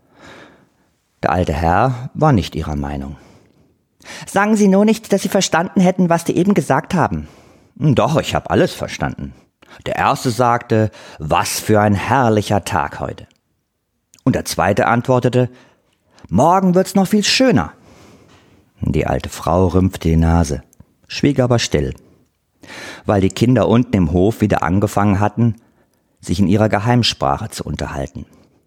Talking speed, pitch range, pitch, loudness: 140 wpm, 85-145 Hz, 110 Hz, -16 LUFS